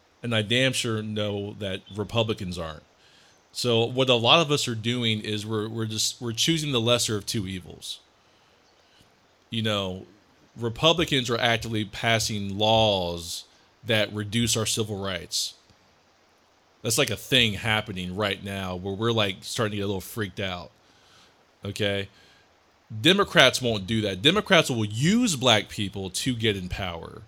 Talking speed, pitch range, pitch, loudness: 155 wpm, 100-120 Hz, 110 Hz, -24 LUFS